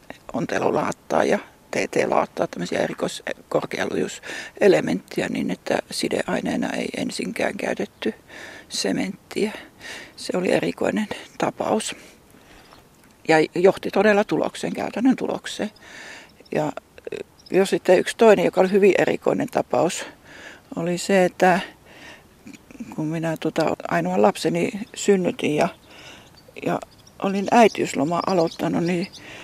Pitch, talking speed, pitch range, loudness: 190 Hz, 95 wpm, 170-210 Hz, -22 LUFS